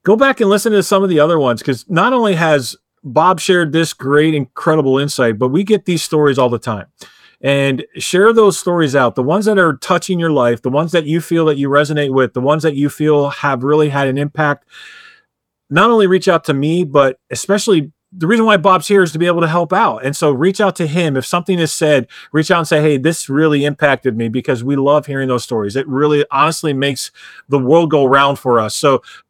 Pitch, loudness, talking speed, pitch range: 150 Hz, -14 LUFS, 235 wpm, 140-180 Hz